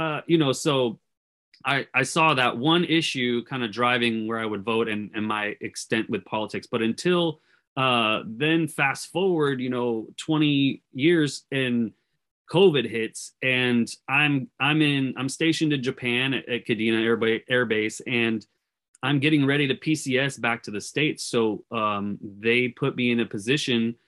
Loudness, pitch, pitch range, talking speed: -24 LUFS, 125 Hz, 115-145 Hz, 165 wpm